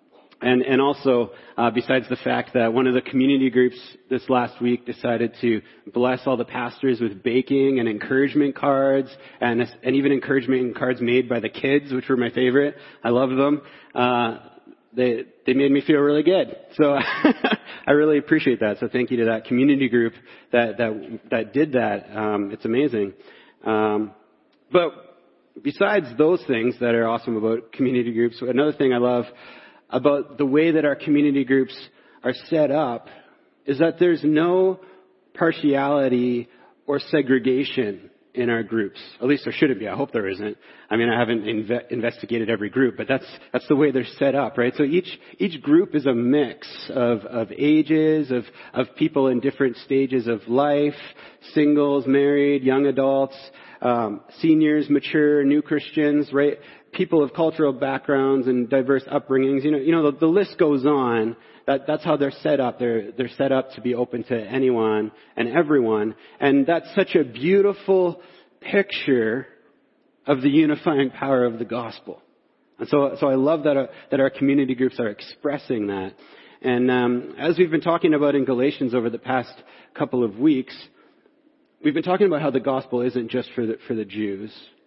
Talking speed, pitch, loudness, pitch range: 175 wpm, 135 Hz, -21 LUFS, 120-145 Hz